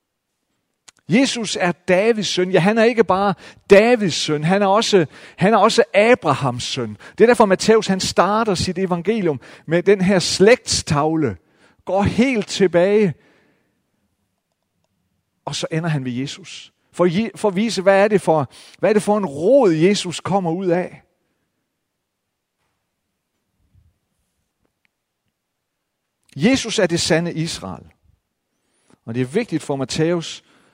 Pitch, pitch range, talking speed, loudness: 180 Hz, 145-205 Hz, 135 wpm, -17 LUFS